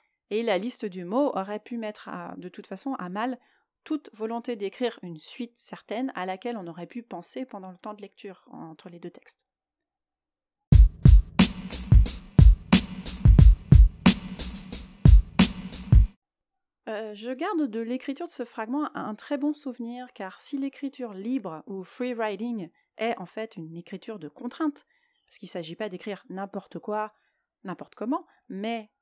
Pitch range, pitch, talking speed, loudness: 195-260 Hz, 225 Hz, 145 wpm, -25 LUFS